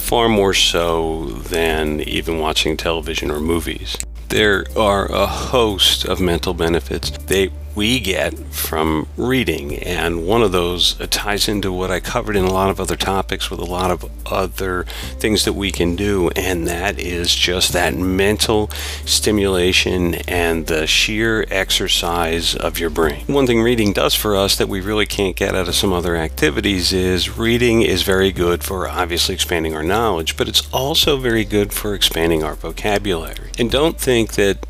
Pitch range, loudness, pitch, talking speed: 80-100 Hz, -17 LUFS, 90 Hz, 170 wpm